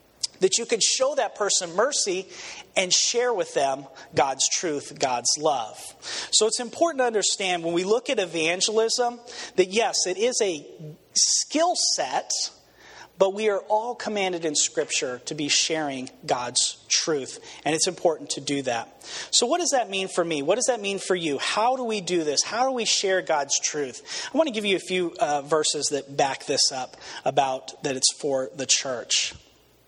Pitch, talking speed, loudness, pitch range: 190 Hz, 185 wpm, -24 LUFS, 160-245 Hz